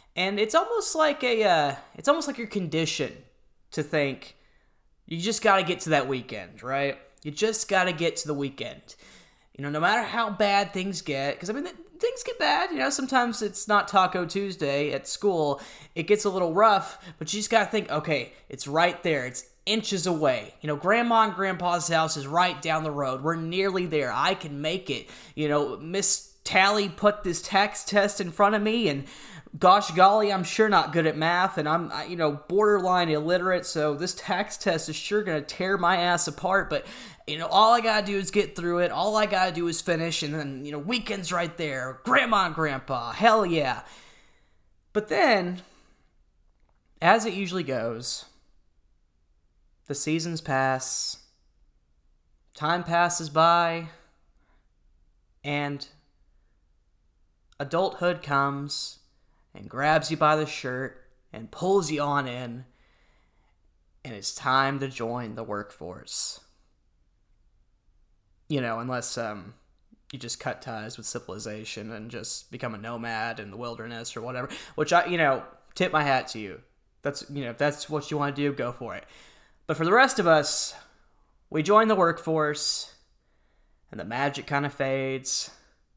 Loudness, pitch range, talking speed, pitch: -25 LUFS, 125-190 Hz, 175 wpm, 155 Hz